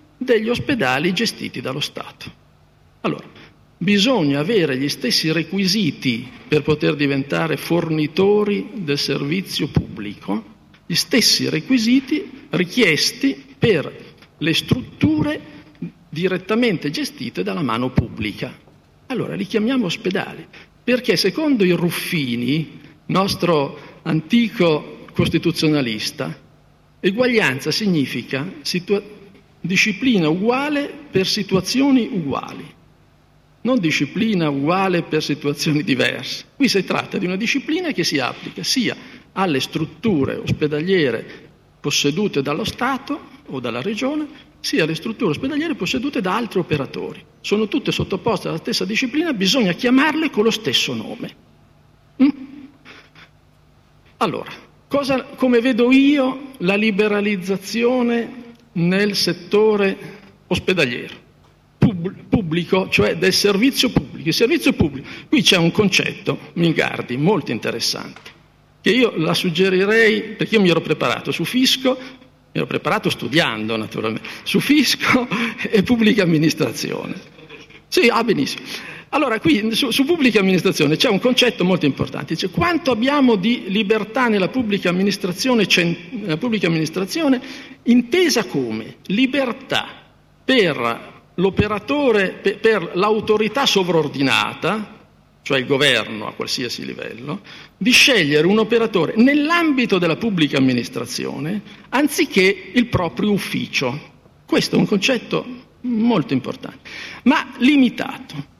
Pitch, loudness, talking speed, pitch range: 205 Hz, -18 LUFS, 110 wpm, 165-245 Hz